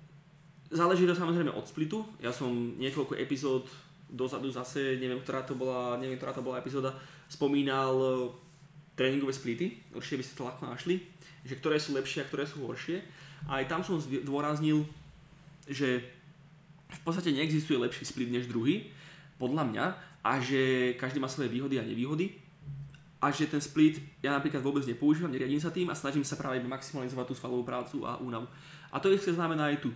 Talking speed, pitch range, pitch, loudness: 175 wpm, 130-155 Hz, 140 Hz, -33 LUFS